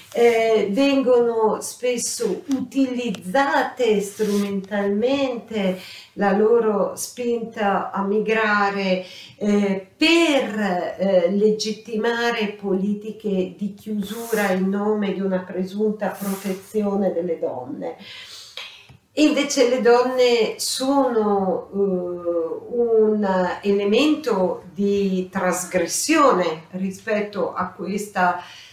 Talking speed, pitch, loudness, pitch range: 75 wpm, 205 Hz, -21 LUFS, 190-235 Hz